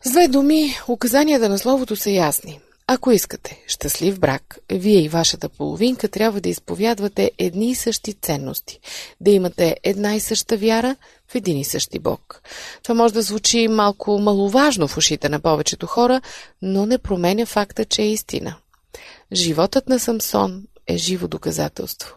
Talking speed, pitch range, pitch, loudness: 160 wpm, 180-235 Hz, 210 Hz, -19 LUFS